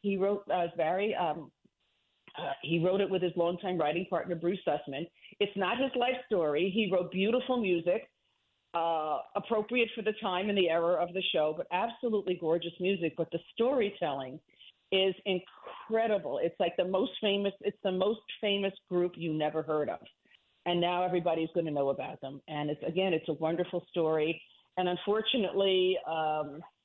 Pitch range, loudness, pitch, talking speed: 165-200 Hz, -32 LUFS, 180 Hz, 175 wpm